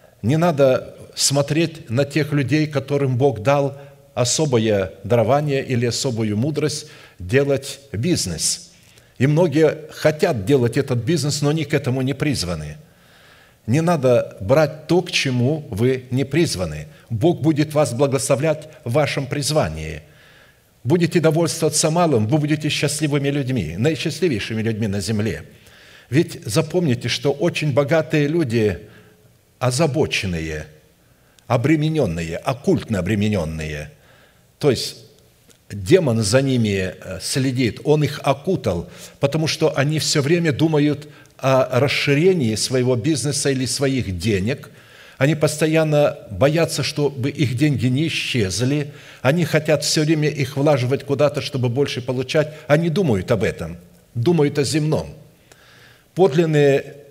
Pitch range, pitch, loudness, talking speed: 125-155 Hz, 140 Hz, -19 LUFS, 120 wpm